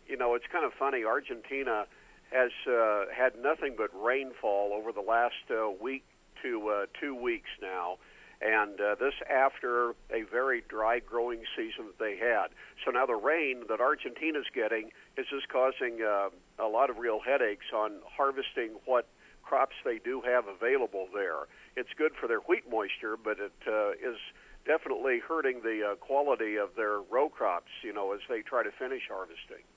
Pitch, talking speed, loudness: 130 Hz, 175 wpm, -32 LUFS